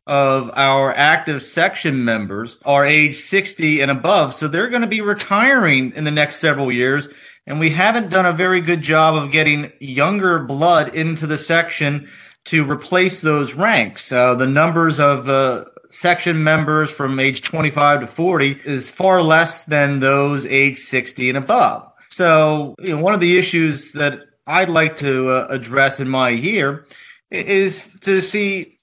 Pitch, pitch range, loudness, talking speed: 150 Hz, 140-175 Hz, -16 LUFS, 165 wpm